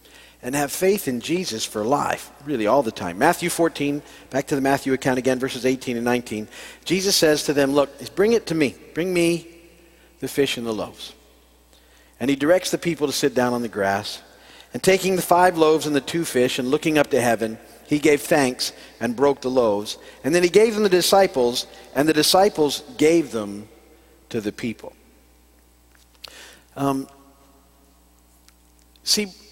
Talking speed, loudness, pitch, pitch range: 180 wpm, -21 LUFS, 140 Hz, 110-165 Hz